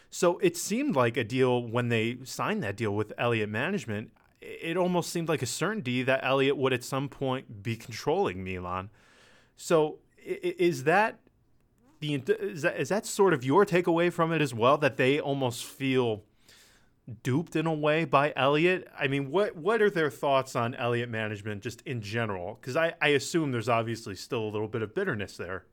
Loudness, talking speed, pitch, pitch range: -28 LUFS, 190 wpm, 135 Hz, 115-165 Hz